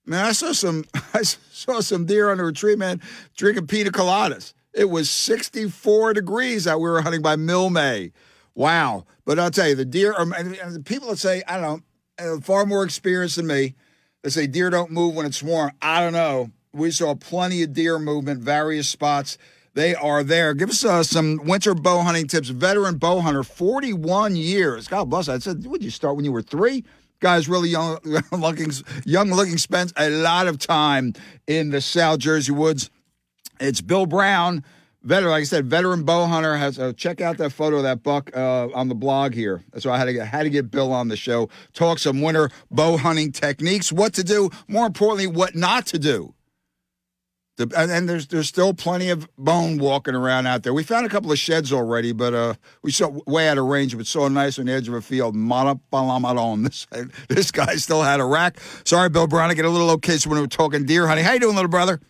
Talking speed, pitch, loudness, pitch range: 210 wpm, 160 Hz, -21 LUFS, 140-180 Hz